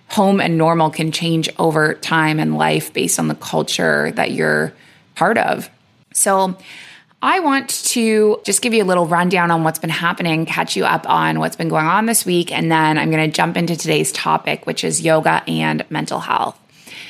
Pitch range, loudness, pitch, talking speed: 155-190 Hz, -16 LUFS, 165 Hz, 195 wpm